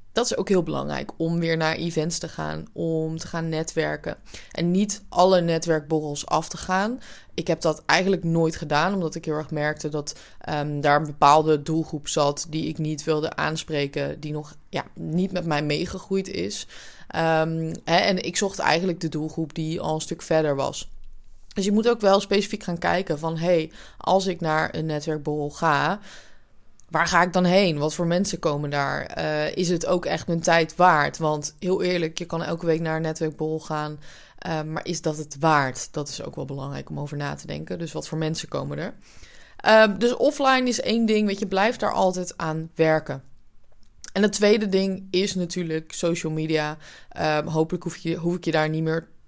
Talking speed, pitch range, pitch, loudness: 200 wpm, 155-180 Hz, 160 Hz, -24 LUFS